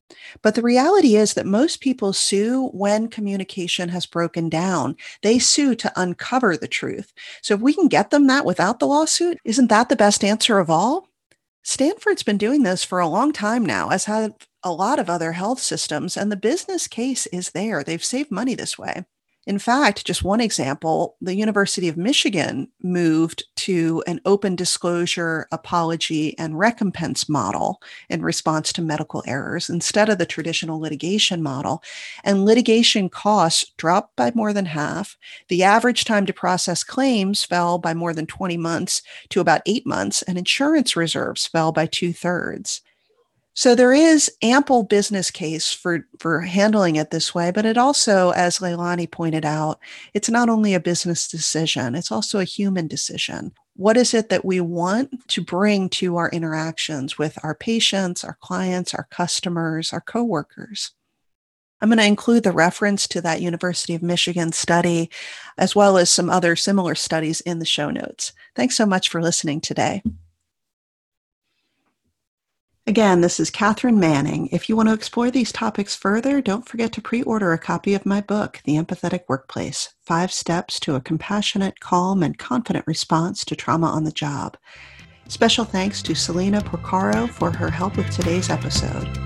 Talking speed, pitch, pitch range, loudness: 170 wpm, 185 Hz, 165-220 Hz, -20 LUFS